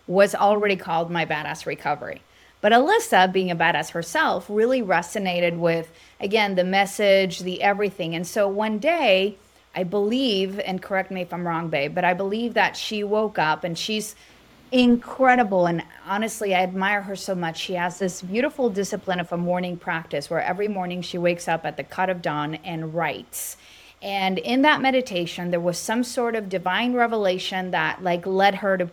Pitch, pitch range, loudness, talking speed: 185 Hz, 175-210 Hz, -23 LUFS, 185 wpm